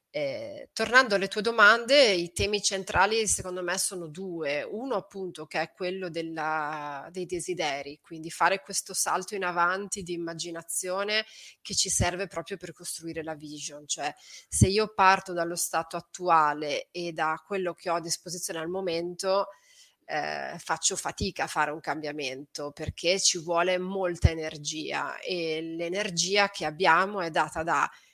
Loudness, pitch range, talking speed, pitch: -28 LUFS, 160-195 Hz, 150 wpm, 175 Hz